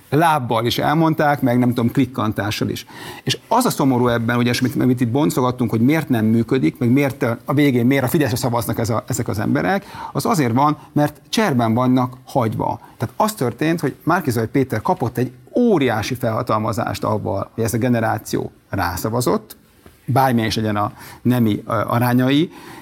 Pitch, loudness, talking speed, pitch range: 125 Hz, -19 LUFS, 170 wpm, 115-140 Hz